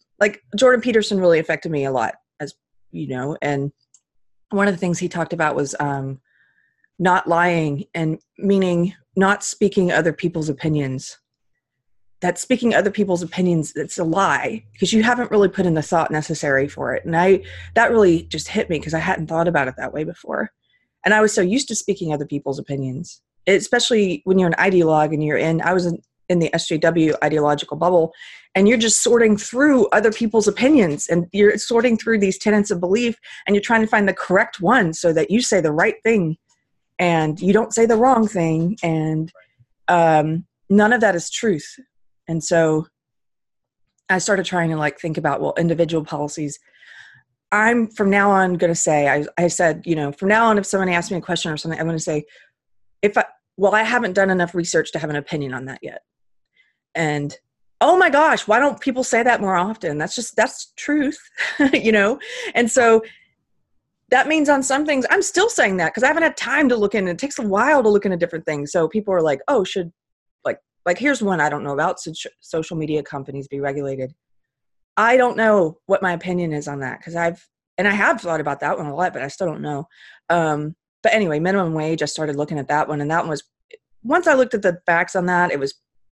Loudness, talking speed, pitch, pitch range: -19 LUFS, 215 wpm, 175 Hz, 155-210 Hz